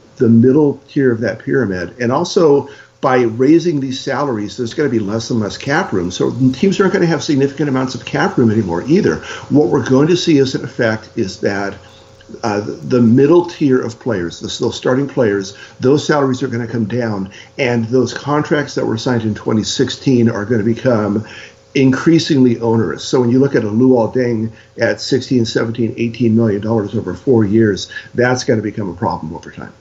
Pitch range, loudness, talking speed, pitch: 110-135 Hz, -15 LUFS, 200 wpm, 120 Hz